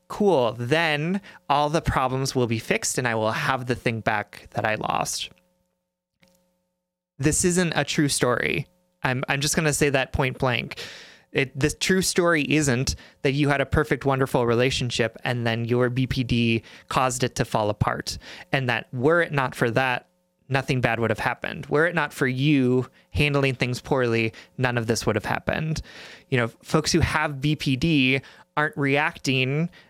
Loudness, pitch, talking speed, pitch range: -23 LUFS, 140 Hz, 175 wpm, 125-155 Hz